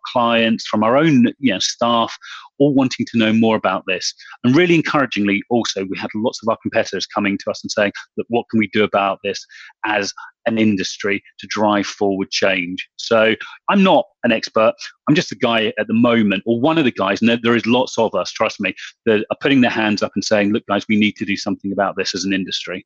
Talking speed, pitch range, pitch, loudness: 230 wpm, 100-115 Hz, 110 Hz, -17 LUFS